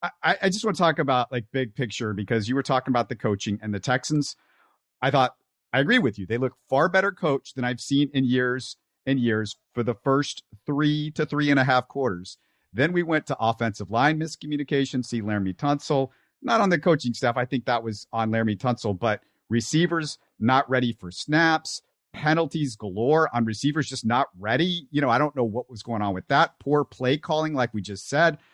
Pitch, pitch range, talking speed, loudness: 130 Hz, 115-150 Hz, 210 wpm, -25 LUFS